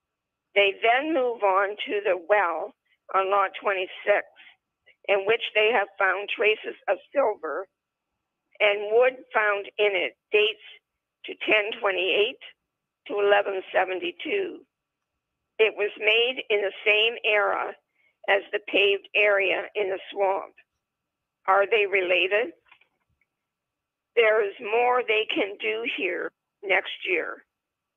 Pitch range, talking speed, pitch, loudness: 200-265 Hz, 115 wpm, 210 Hz, -24 LUFS